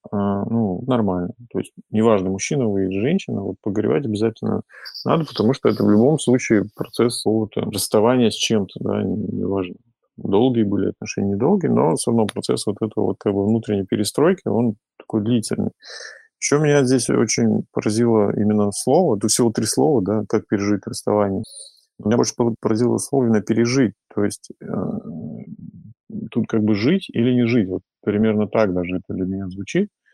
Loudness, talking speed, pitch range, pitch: -20 LUFS, 165 wpm, 100-115 Hz, 110 Hz